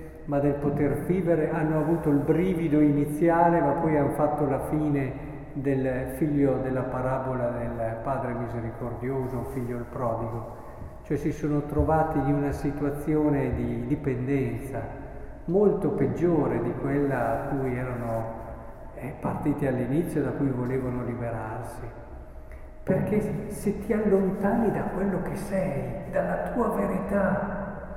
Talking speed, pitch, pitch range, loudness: 125 wpm, 145 Hz, 125-160 Hz, -27 LUFS